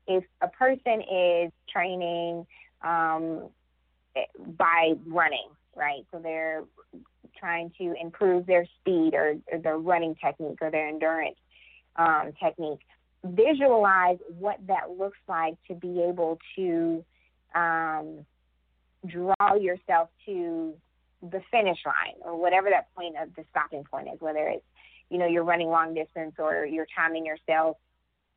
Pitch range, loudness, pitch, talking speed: 155-180 Hz, -27 LUFS, 165 Hz, 135 wpm